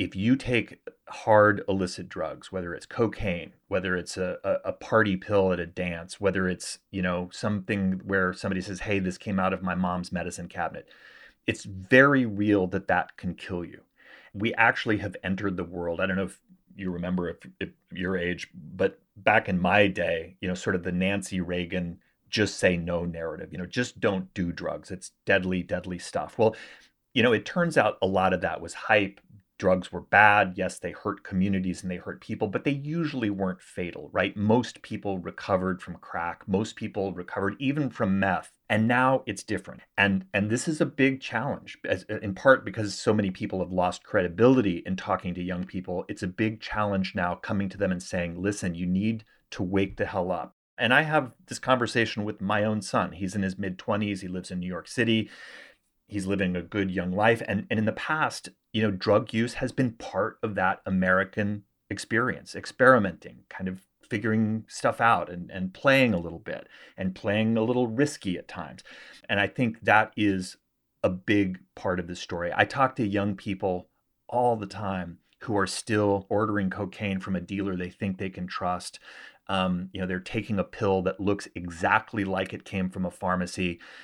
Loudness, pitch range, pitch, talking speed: -27 LUFS, 90-110 Hz, 95 Hz, 200 wpm